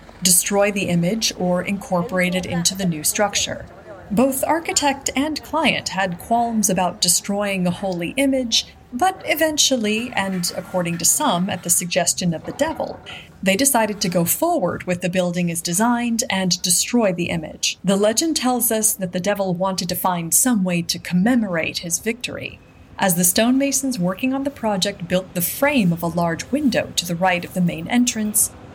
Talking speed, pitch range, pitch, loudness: 175 wpm, 180-245 Hz, 195 Hz, -19 LUFS